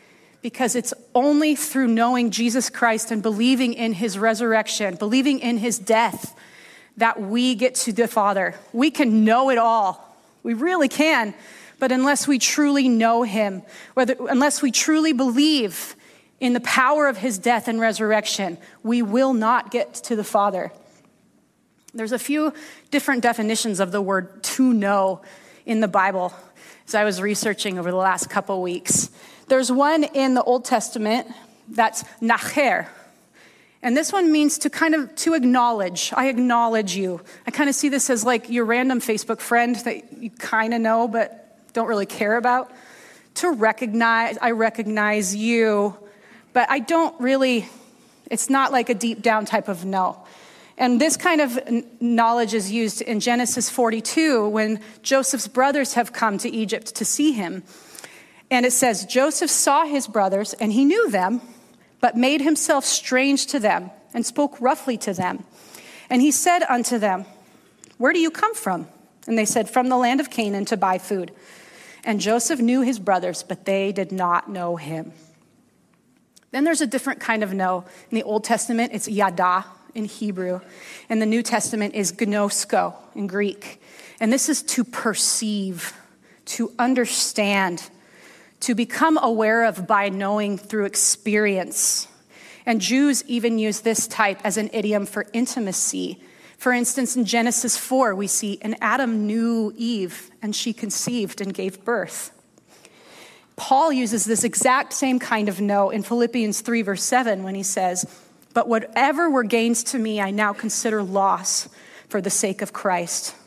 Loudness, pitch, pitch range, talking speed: -21 LUFS, 230 Hz, 210-255 Hz, 165 wpm